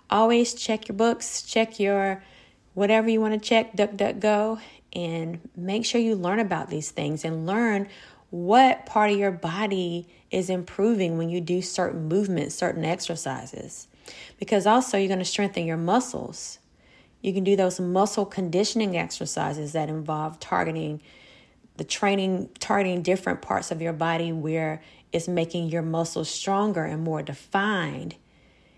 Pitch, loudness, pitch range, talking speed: 185 Hz, -25 LUFS, 165-210 Hz, 150 wpm